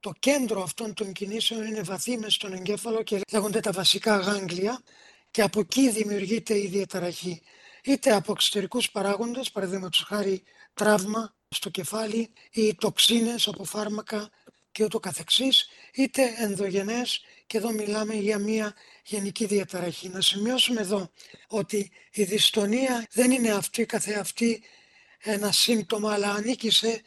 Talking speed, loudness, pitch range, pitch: 135 wpm, -26 LUFS, 200-225 Hz, 210 Hz